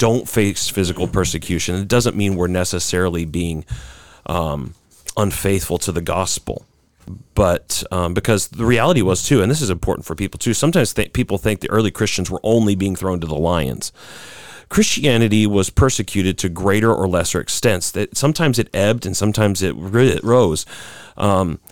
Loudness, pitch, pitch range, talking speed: -18 LUFS, 95 Hz, 90-110 Hz, 170 wpm